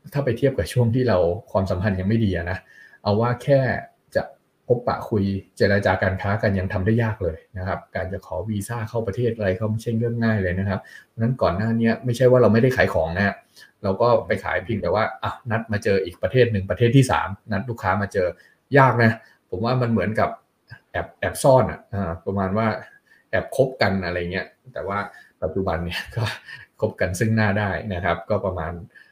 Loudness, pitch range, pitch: -22 LUFS, 95-115 Hz, 105 Hz